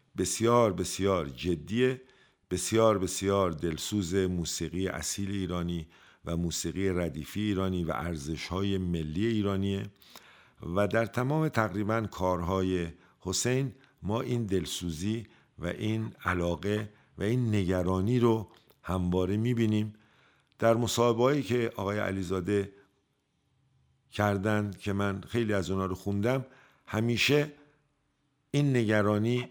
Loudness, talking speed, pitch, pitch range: -30 LUFS, 110 wpm, 100 Hz, 90-115 Hz